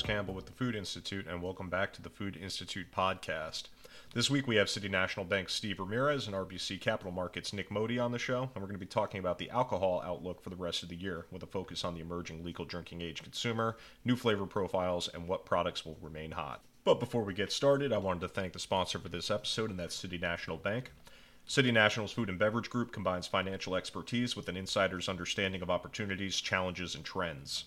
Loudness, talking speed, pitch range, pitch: -35 LUFS, 225 wpm, 90-105 Hz, 95 Hz